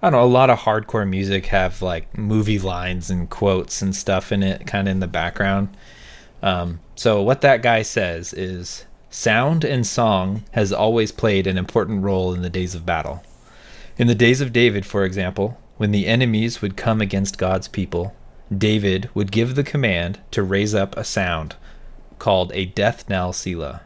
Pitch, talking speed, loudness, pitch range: 100 Hz, 185 wpm, -20 LUFS, 95-110 Hz